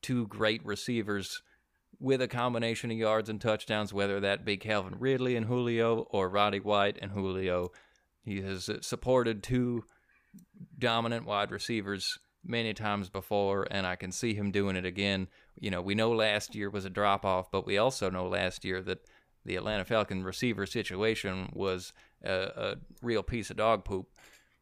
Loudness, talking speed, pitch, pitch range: -32 LUFS, 170 wpm, 105 Hz, 100-115 Hz